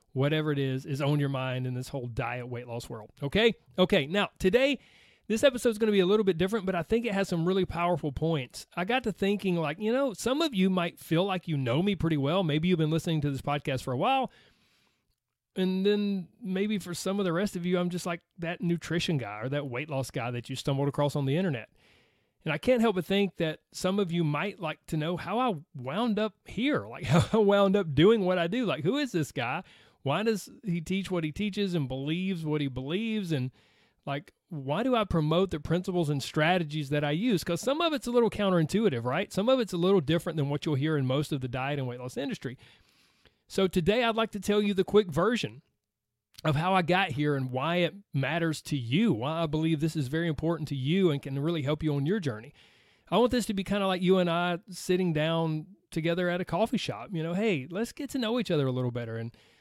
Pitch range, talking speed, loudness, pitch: 145-200 Hz, 250 wpm, -29 LUFS, 170 Hz